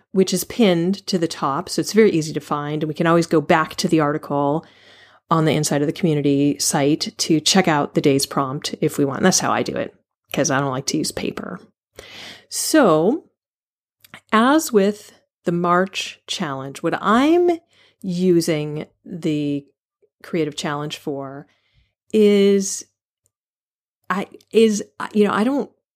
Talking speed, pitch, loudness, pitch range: 160 wpm, 170 Hz, -19 LUFS, 150-205 Hz